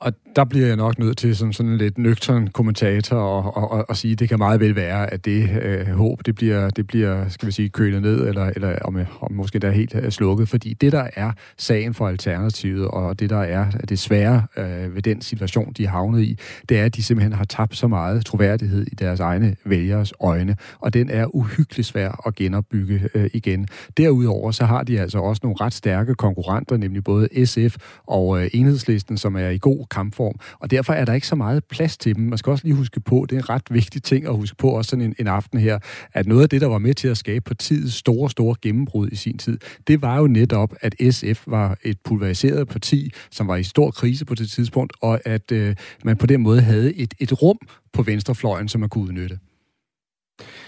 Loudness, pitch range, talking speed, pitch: -20 LUFS, 100-125 Hz, 235 wpm, 110 Hz